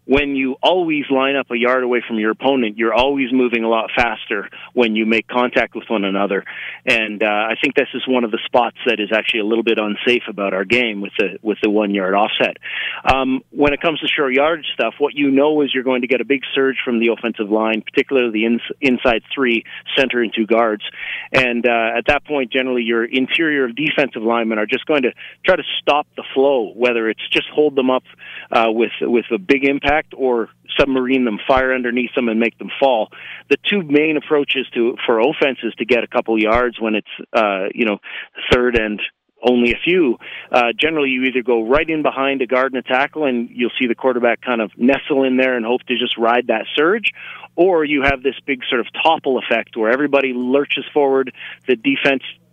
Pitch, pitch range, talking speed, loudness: 125 Hz, 115-140 Hz, 215 wpm, -17 LUFS